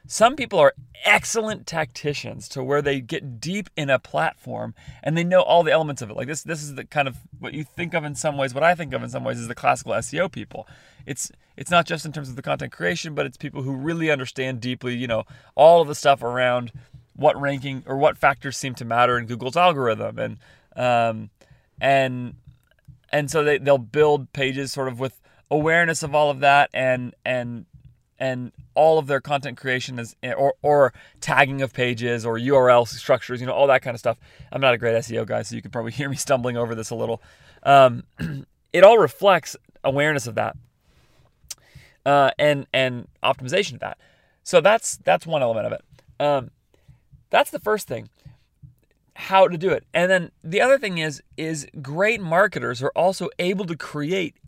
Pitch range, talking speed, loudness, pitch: 125-155 Hz, 200 wpm, -21 LUFS, 140 Hz